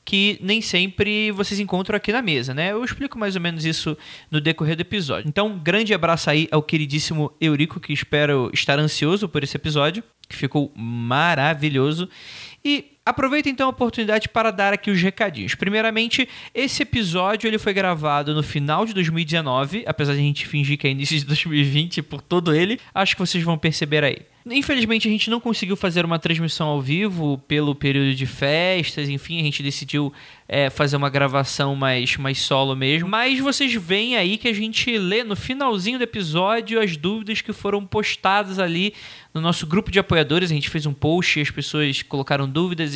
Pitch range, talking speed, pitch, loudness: 145-210 Hz, 185 wpm, 170 Hz, -21 LUFS